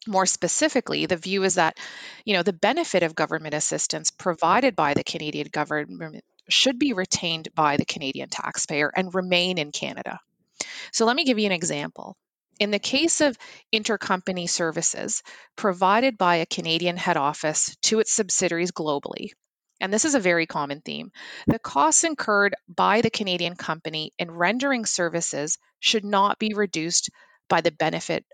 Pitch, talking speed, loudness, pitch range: 185 Hz, 160 wpm, -23 LUFS, 165-220 Hz